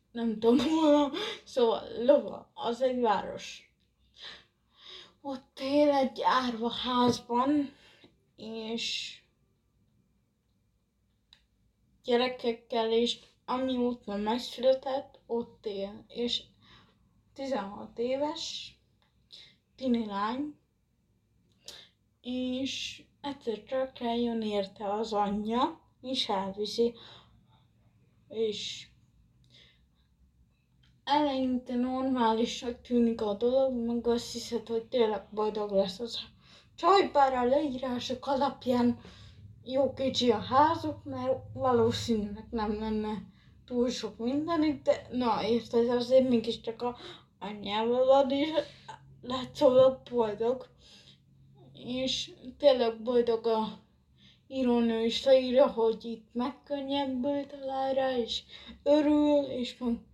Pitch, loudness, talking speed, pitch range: 245 Hz, -30 LUFS, 90 wpm, 225-265 Hz